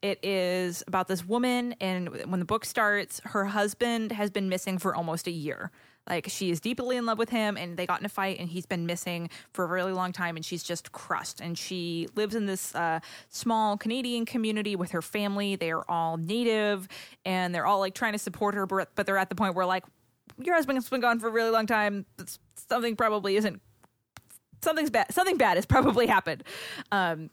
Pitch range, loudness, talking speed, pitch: 180-220 Hz, -29 LUFS, 215 wpm, 195 Hz